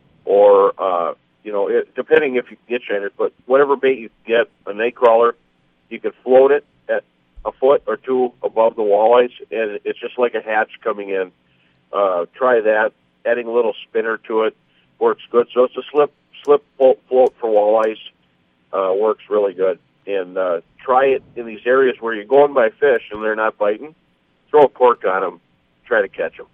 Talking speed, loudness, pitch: 195 wpm, -17 LUFS, 125 Hz